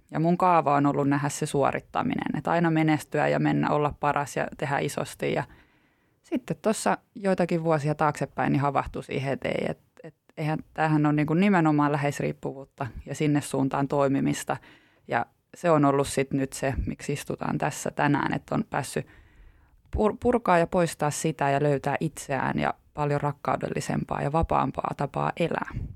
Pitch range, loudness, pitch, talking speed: 140-160 Hz, -26 LUFS, 145 Hz, 155 wpm